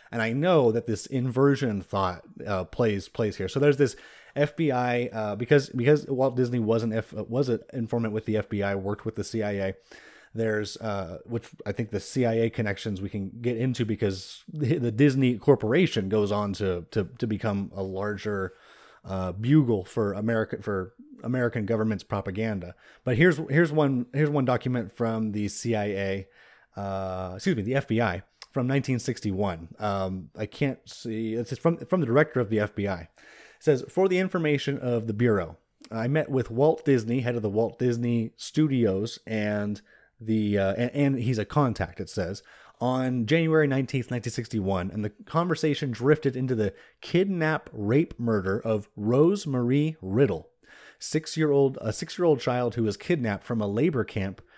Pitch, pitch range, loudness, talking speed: 115 Hz, 105-135 Hz, -27 LUFS, 170 wpm